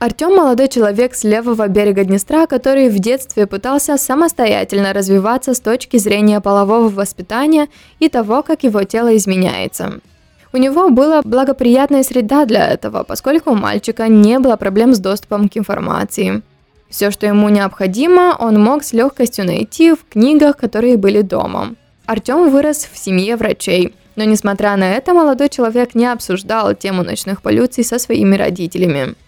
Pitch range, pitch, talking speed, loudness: 205-265 Hz, 230 Hz, 150 wpm, -13 LUFS